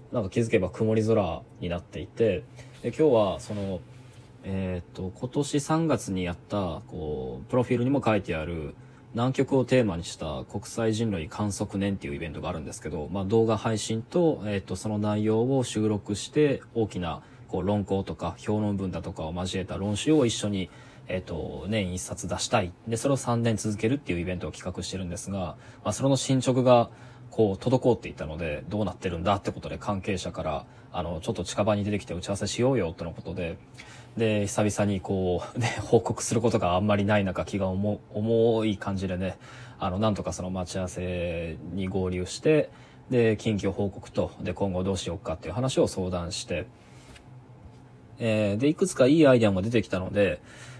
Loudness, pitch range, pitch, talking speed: -28 LUFS, 90-120 Hz, 105 Hz, 375 characters per minute